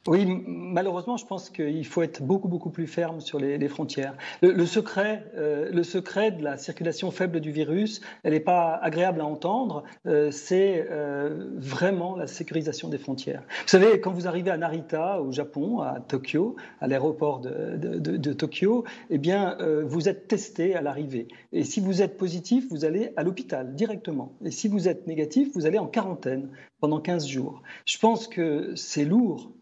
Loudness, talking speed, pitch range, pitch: -27 LUFS, 190 wpm, 150-190 Hz, 170 Hz